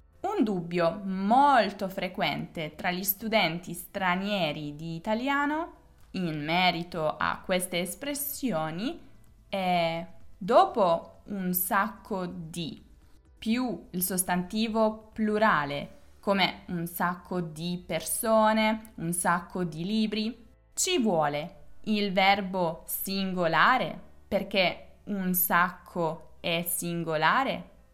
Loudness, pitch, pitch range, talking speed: -28 LUFS, 185 Hz, 170-215 Hz, 90 wpm